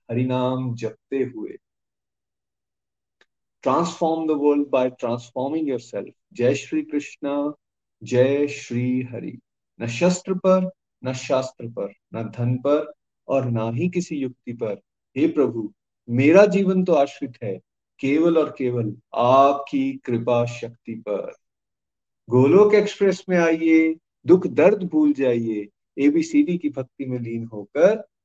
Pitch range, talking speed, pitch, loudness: 120-165 Hz, 125 wpm, 135 Hz, -21 LUFS